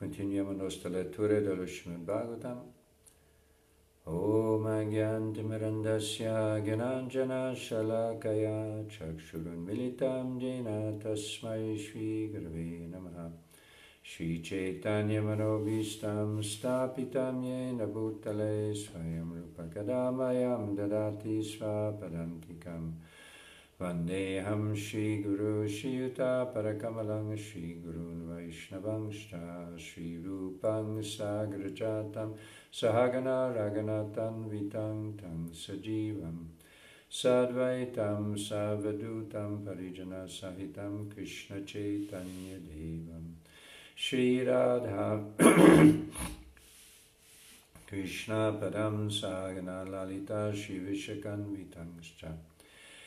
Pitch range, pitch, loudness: 90-110 Hz, 105 Hz, -34 LUFS